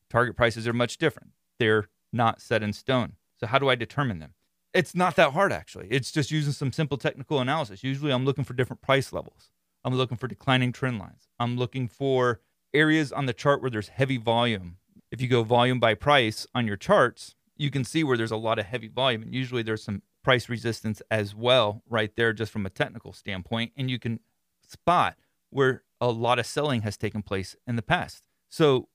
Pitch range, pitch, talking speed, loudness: 110-135 Hz, 120 Hz, 210 wpm, -26 LUFS